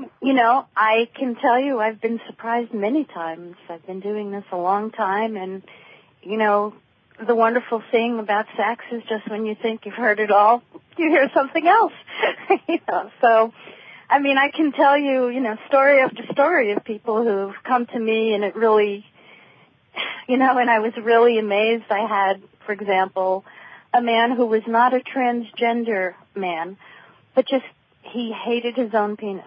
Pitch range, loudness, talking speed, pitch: 210-250 Hz, -20 LUFS, 180 wpm, 225 Hz